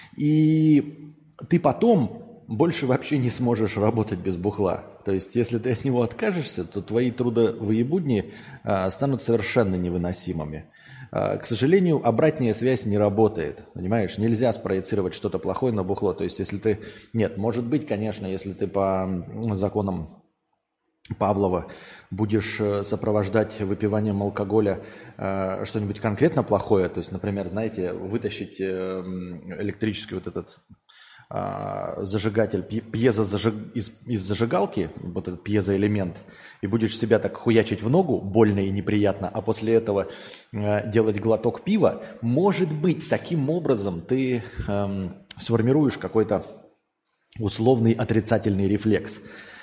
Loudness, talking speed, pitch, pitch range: -24 LUFS, 130 wpm, 110 Hz, 100-120 Hz